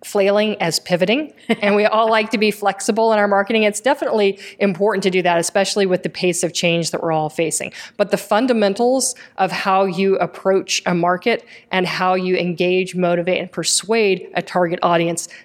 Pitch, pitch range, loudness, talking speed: 195 Hz, 180-210 Hz, -18 LUFS, 185 wpm